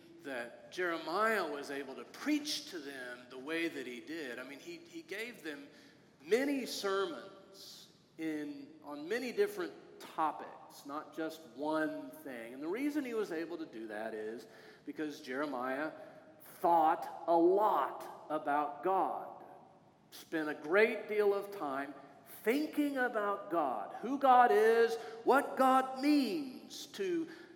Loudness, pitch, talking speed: -35 LUFS, 205 Hz, 135 wpm